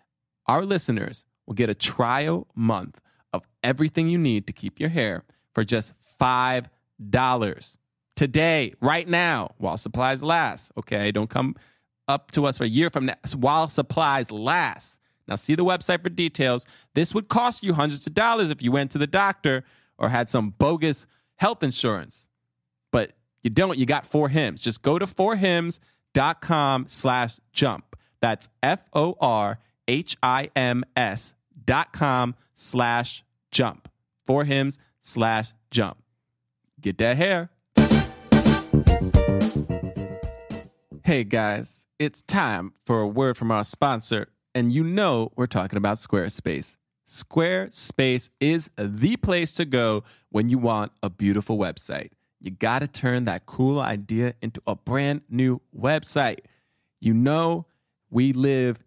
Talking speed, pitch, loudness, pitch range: 140 wpm, 125 Hz, -24 LUFS, 110-150 Hz